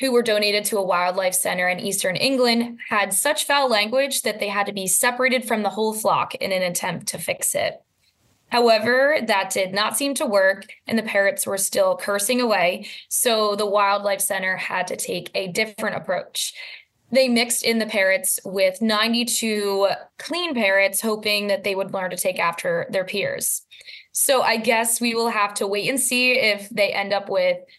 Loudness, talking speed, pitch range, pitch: -21 LUFS, 190 wpm, 195-245 Hz, 210 Hz